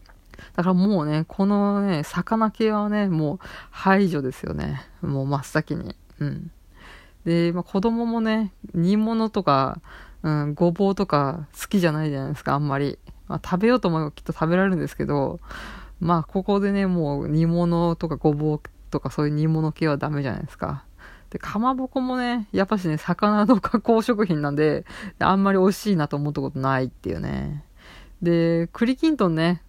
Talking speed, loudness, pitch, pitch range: 345 characters per minute, -23 LUFS, 170 Hz, 150-200 Hz